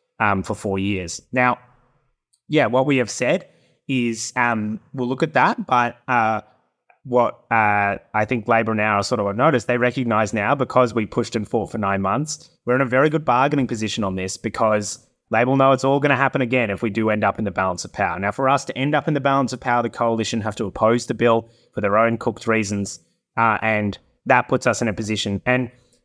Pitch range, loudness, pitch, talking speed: 110-125 Hz, -20 LUFS, 115 Hz, 230 wpm